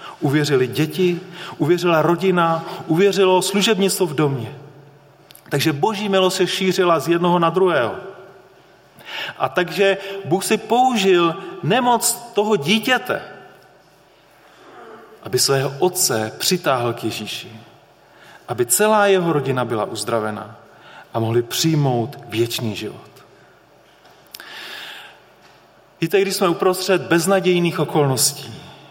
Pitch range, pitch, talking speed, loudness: 145-190 Hz, 175 Hz, 100 wpm, -18 LUFS